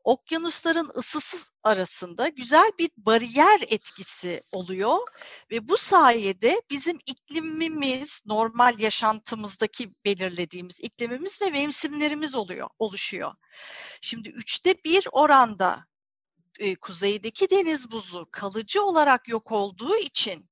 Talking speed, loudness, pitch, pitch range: 100 wpm, -24 LUFS, 245 Hz, 215-320 Hz